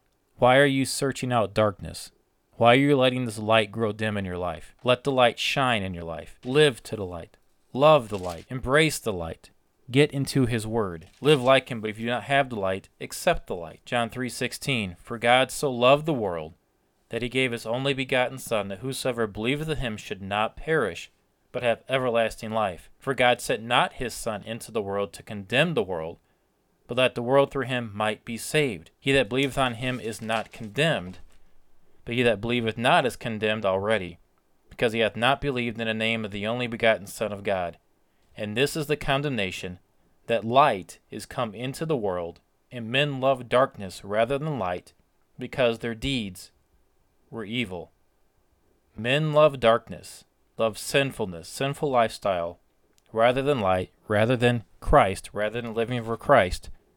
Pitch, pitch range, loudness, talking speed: 115 Hz, 105-130 Hz, -25 LUFS, 185 wpm